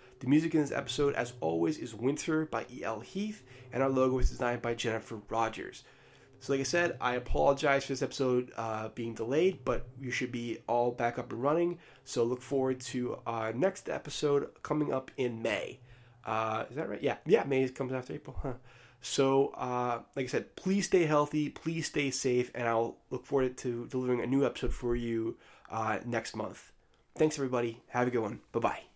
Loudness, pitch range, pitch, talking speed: -32 LUFS, 120-140 Hz, 125 Hz, 200 wpm